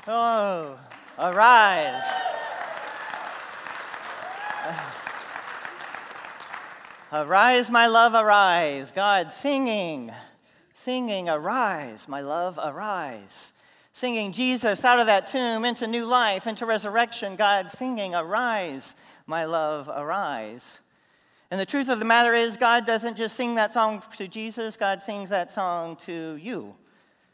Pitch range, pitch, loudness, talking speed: 185-235 Hz, 215 Hz, -23 LUFS, 115 wpm